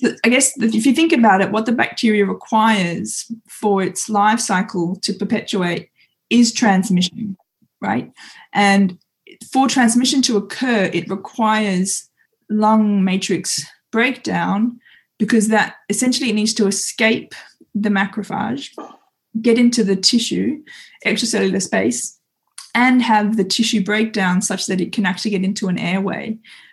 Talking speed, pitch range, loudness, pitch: 130 wpm, 195-235 Hz, -17 LUFS, 215 Hz